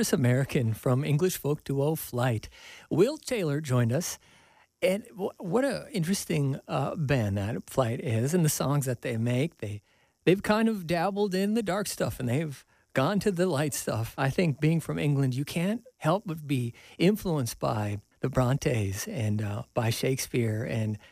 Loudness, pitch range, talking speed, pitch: -28 LUFS, 120-180 Hz, 175 wpm, 140 Hz